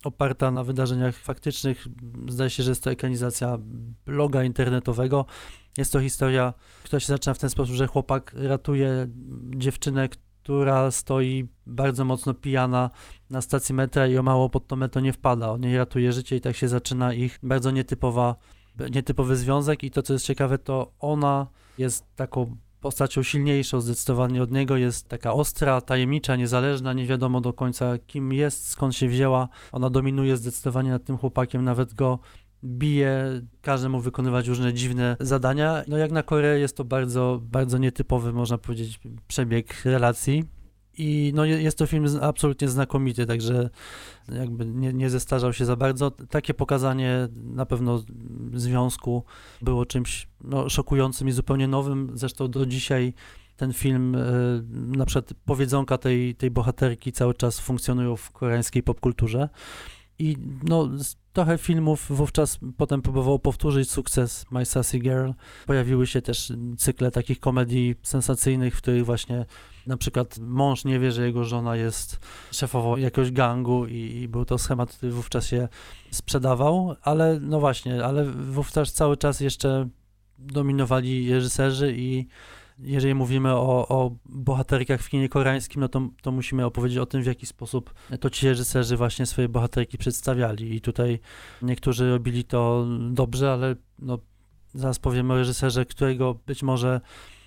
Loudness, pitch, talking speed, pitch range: -25 LUFS, 130 Hz, 155 wpm, 125-135 Hz